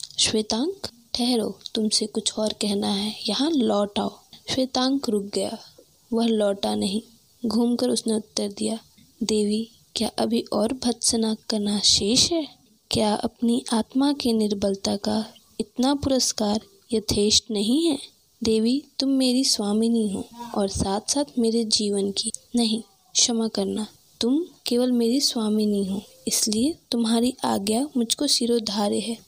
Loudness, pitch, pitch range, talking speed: -23 LUFS, 225 Hz, 210-245 Hz, 135 wpm